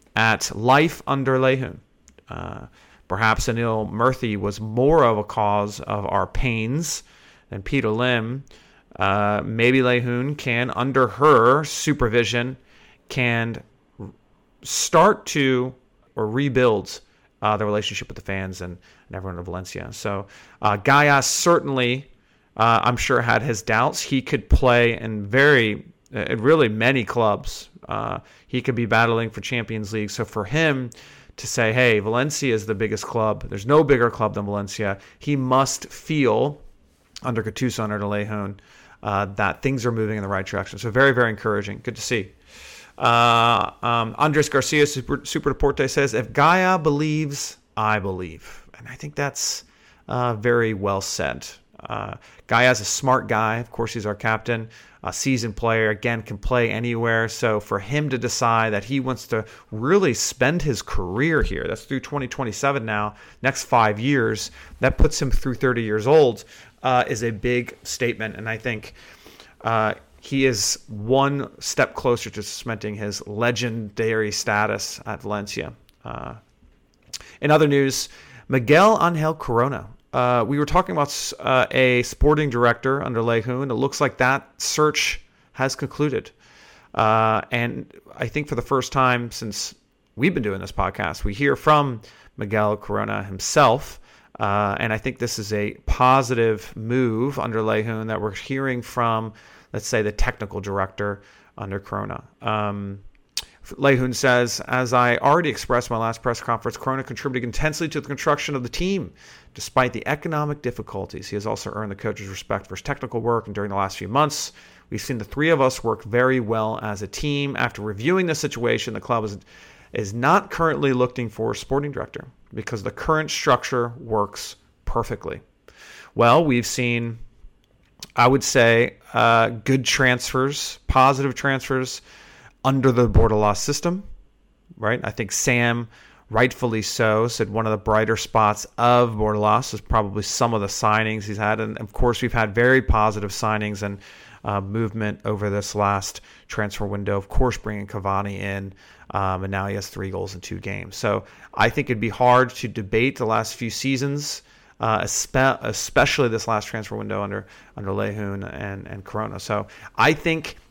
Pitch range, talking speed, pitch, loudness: 105-130 Hz, 165 wpm, 115 Hz, -22 LUFS